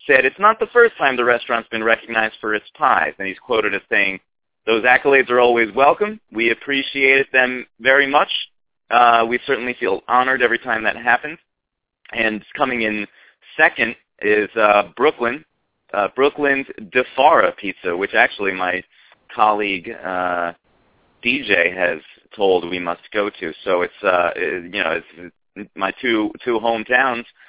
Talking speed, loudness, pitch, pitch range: 155 wpm, -17 LUFS, 115 Hz, 105-130 Hz